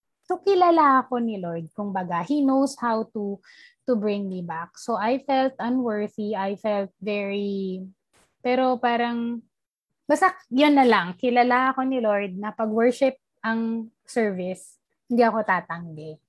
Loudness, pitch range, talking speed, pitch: -24 LUFS, 200-260 Hz, 145 wpm, 225 Hz